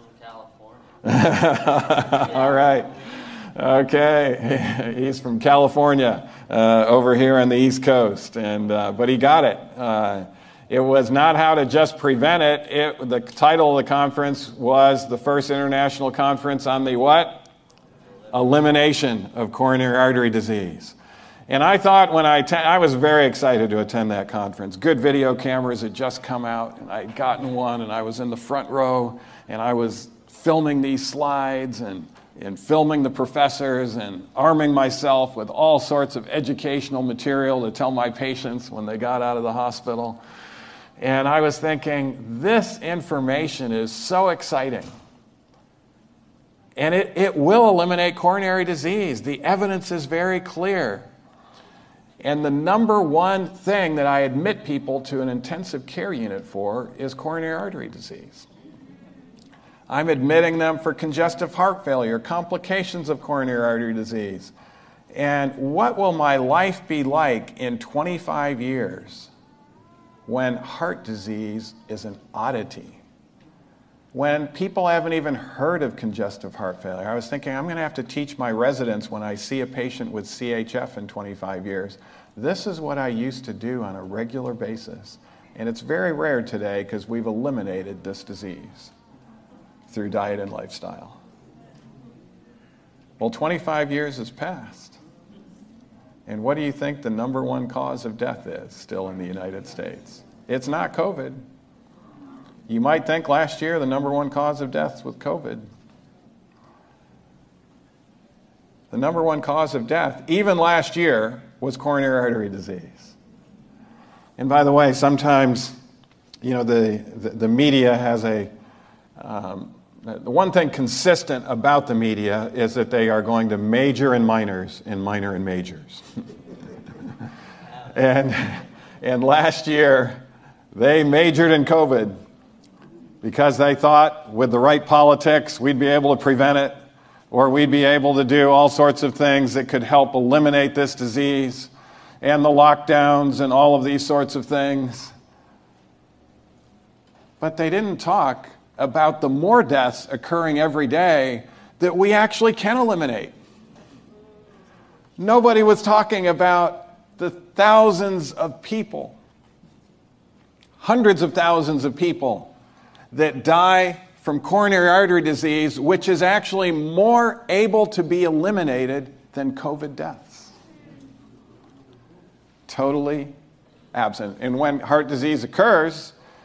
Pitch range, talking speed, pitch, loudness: 120-155 Hz, 145 wpm, 140 Hz, -20 LUFS